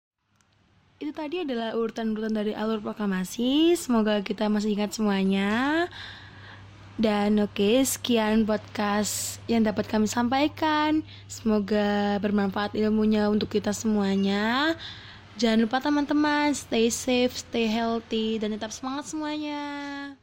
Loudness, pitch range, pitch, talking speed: -26 LUFS, 210-265 Hz, 220 Hz, 115 wpm